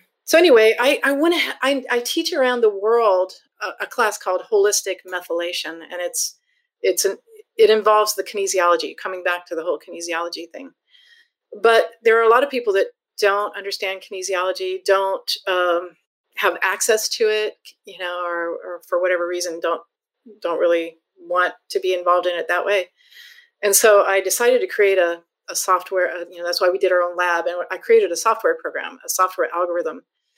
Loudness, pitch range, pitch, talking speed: -19 LUFS, 180-275 Hz, 195 Hz, 180 wpm